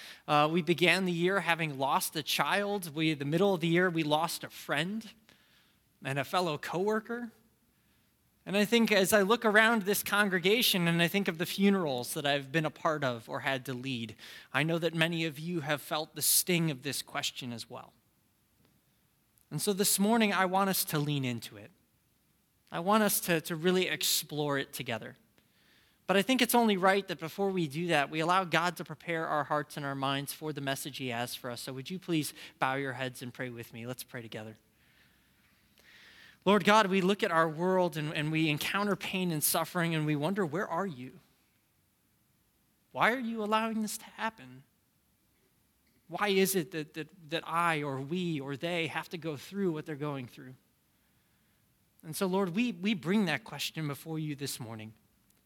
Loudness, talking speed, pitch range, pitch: -30 LUFS, 200 wpm, 140-190 Hz, 165 Hz